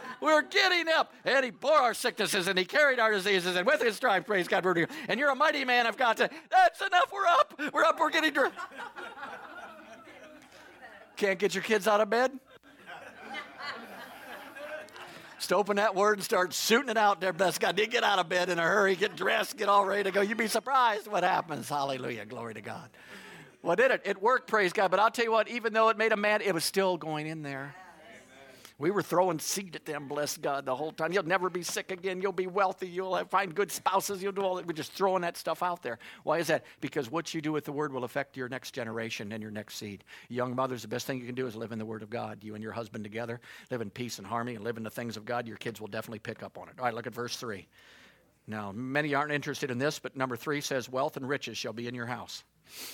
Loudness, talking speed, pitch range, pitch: -29 LUFS, 250 wpm, 125-215 Hz, 180 Hz